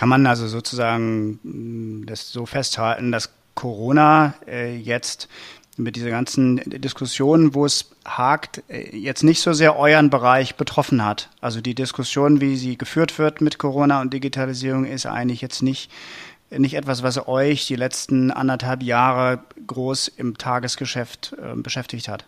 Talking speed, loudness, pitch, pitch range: 145 wpm, -20 LUFS, 130 Hz, 120-140 Hz